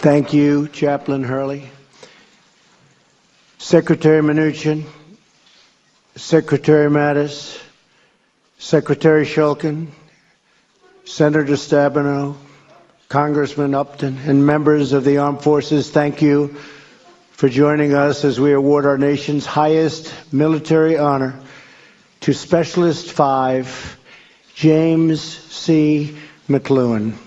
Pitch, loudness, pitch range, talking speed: 145 Hz, -16 LUFS, 140-155 Hz, 85 wpm